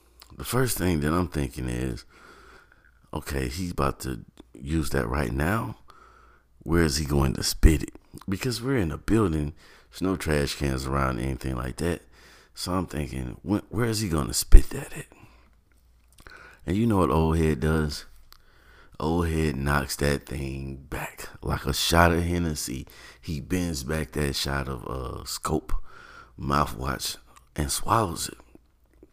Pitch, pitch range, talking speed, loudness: 75 Hz, 70-85 Hz, 165 wpm, -27 LUFS